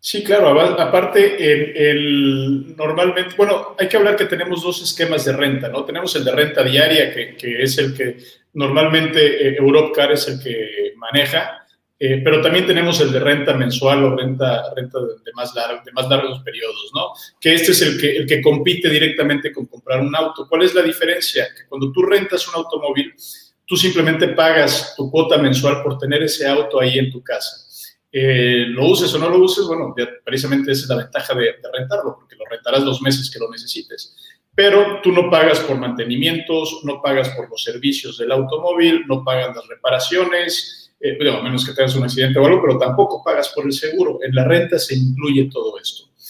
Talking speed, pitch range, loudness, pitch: 200 wpm, 135-180 Hz, -16 LUFS, 150 Hz